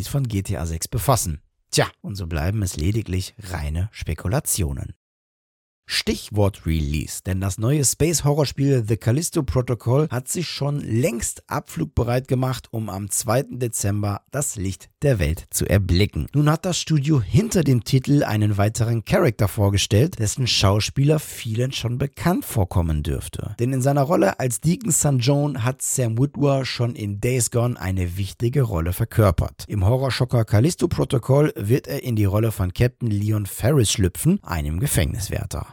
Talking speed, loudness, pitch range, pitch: 150 wpm, -22 LUFS, 100-135 Hz, 115 Hz